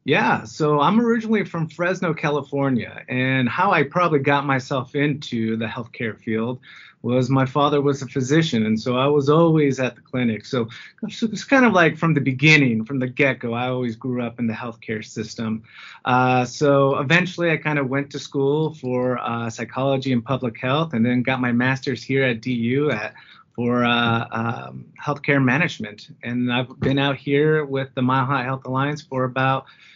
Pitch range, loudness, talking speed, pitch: 120-145 Hz, -21 LUFS, 185 wpm, 130 Hz